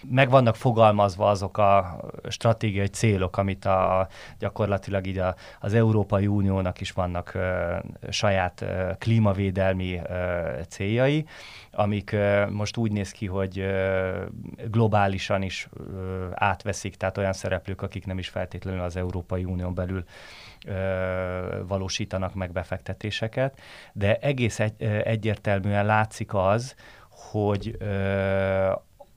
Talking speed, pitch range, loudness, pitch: 120 wpm, 95-105 Hz, -26 LUFS, 100 Hz